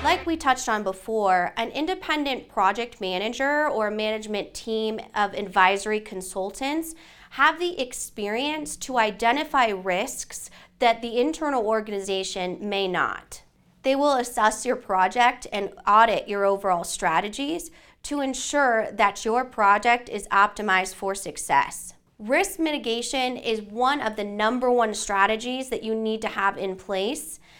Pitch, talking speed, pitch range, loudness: 220 Hz, 135 wpm, 200-260 Hz, -24 LUFS